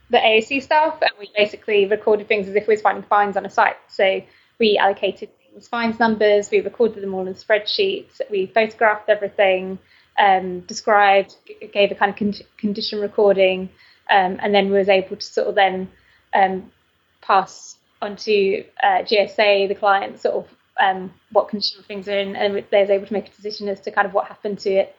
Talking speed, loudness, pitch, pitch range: 200 wpm, -19 LUFS, 205 Hz, 195-220 Hz